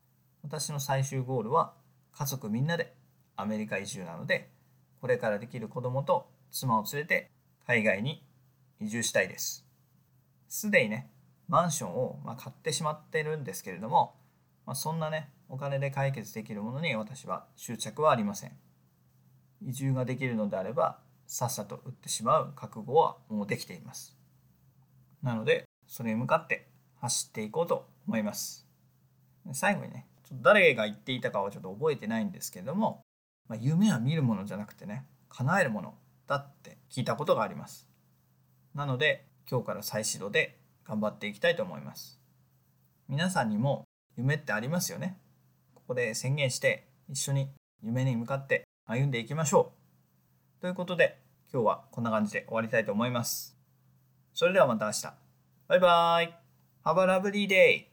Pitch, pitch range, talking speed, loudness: 130 Hz, 105-150 Hz, 340 characters per minute, -30 LUFS